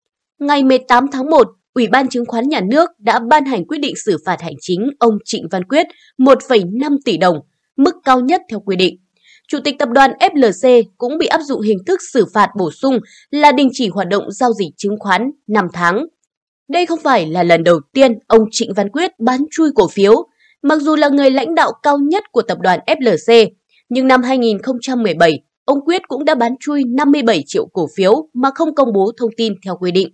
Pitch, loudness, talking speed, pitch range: 255 Hz, -14 LUFS, 215 wpm, 210-290 Hz